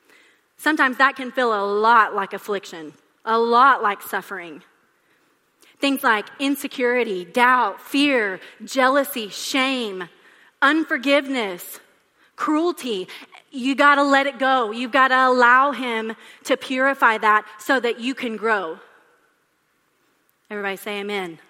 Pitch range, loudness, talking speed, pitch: 215-275 Hz, -19 LUFS, 115 wpm, 250 Hz